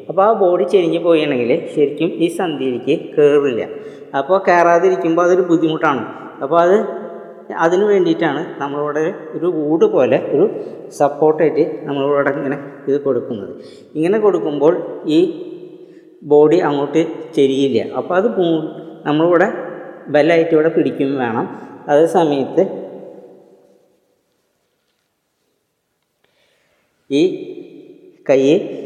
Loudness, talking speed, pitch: -16 LUFS, 95 wpm, 170 Hz